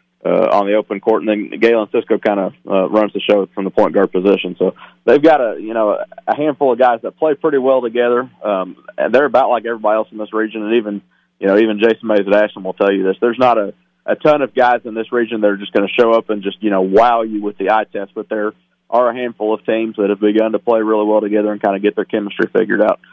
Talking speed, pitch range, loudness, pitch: 275 wpm, 105-115 Hz, -15 LUFS, 110 Hz